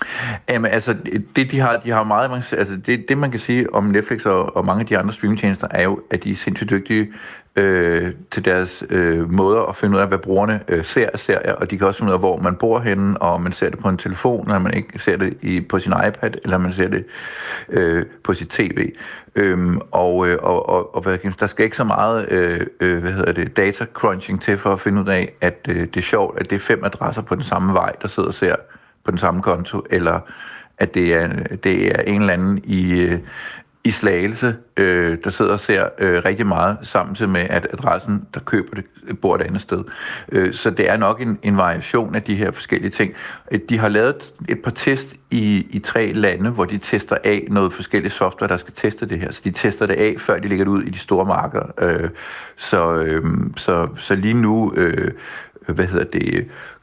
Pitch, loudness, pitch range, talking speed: 100 Hz, -19 LUFS, 90-105 Hz, 230 wpm